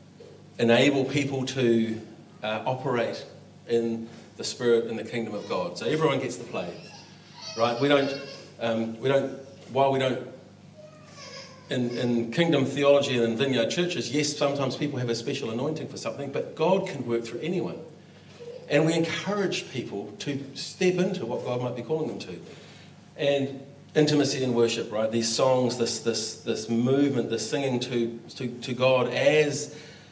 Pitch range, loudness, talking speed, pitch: 115-150 Hz, -26 LUFS, 165 wpm, 135 Hz